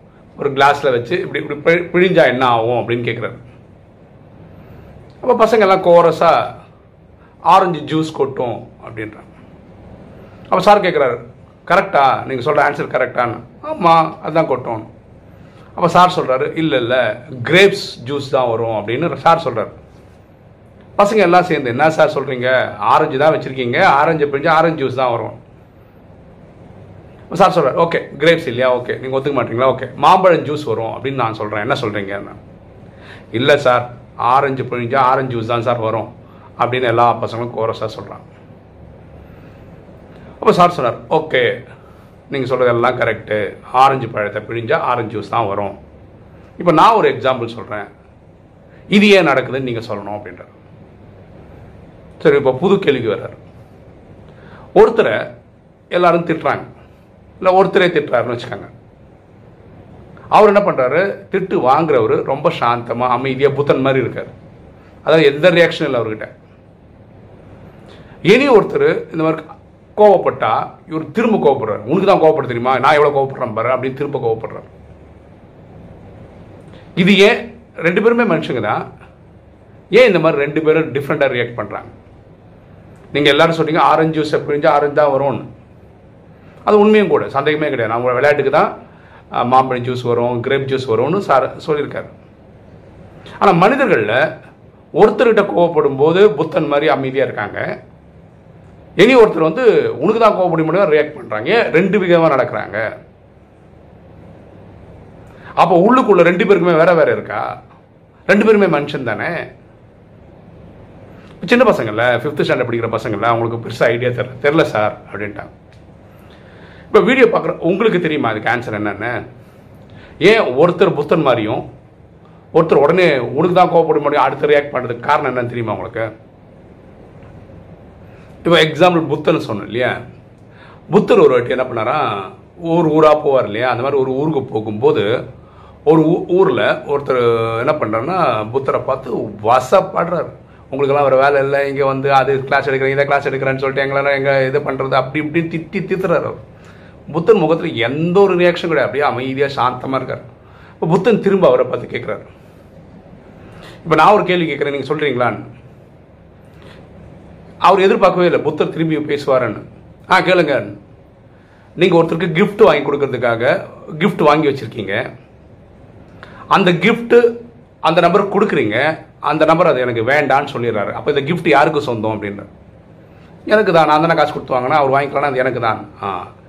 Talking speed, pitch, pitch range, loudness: 130 wpm, 140 Hz, 120-170 Hz, -14 LUFS